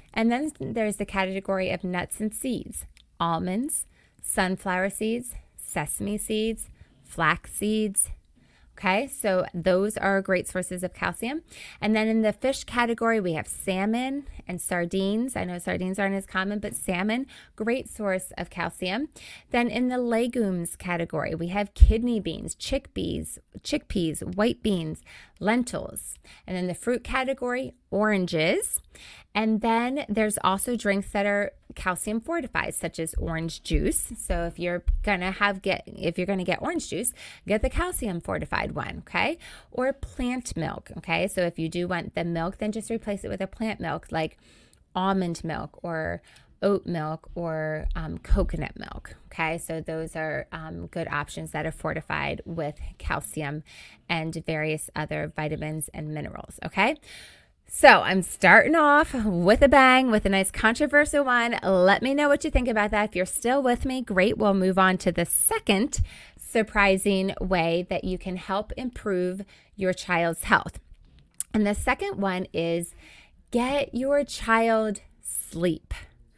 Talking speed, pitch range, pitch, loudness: 155 wpm, 175-230 Hz, 195 Hz, -26 LUFS